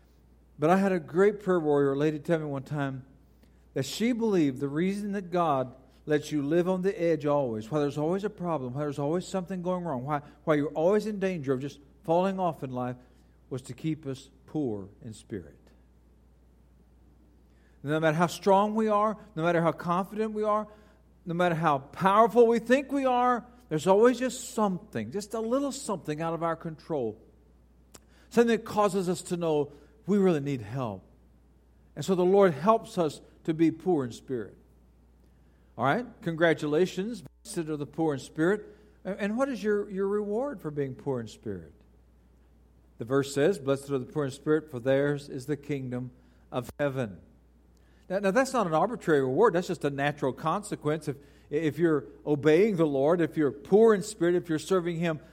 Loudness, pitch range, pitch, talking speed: -28 LUFS, 130-190 Hz, 155 Hz, 185 wpm